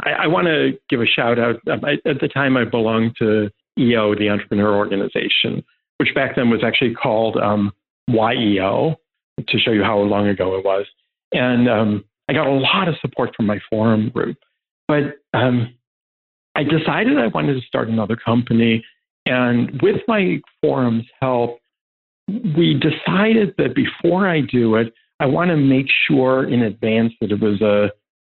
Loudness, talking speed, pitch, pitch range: -18 LUFS, 170 wpm, 115 Hz, 105-140 Hz